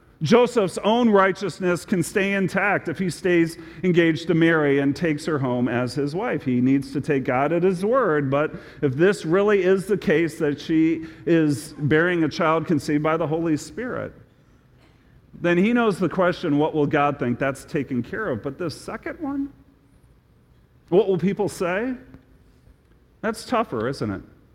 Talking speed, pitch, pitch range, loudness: 170 wpm, 165 Hz, 145-190 Hz, -22 LUFS